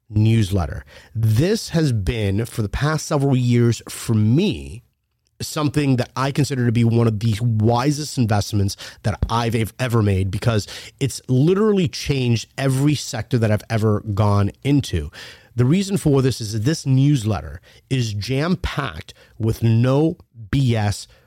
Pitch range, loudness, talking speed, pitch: 110-135 Hz, -20 LUFS, 145 wpm, 120 Hz